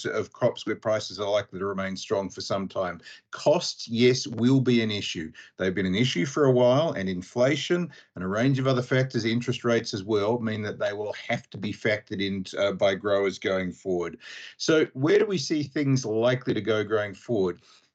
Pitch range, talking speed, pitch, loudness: 100-130 Hz, 205 wpm, 115 Hz, -26 LUFS